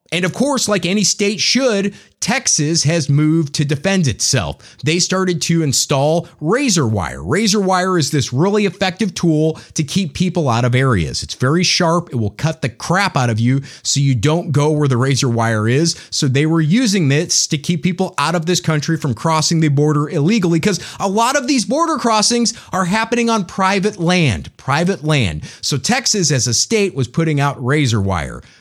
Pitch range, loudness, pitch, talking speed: 140-190 Hz, -16 LUFS, 165 Hz, 195 wpm